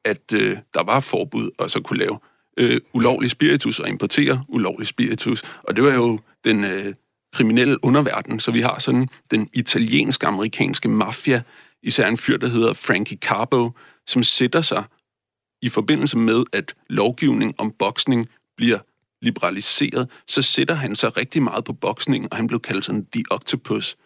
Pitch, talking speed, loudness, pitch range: 120 Hz, 160 wpm, -20 LUFS, 110-125 Hz